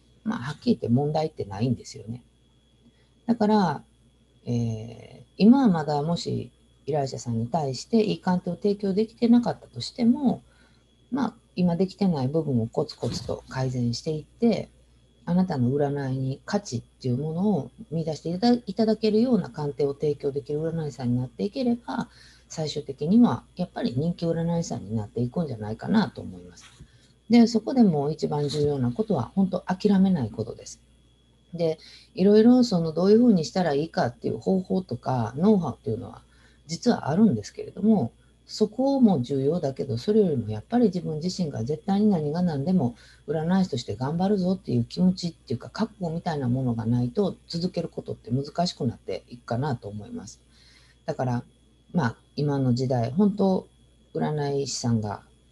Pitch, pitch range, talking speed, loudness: 155 Hz, 125-200 Hz, 370 characters per minute, -25 LUFS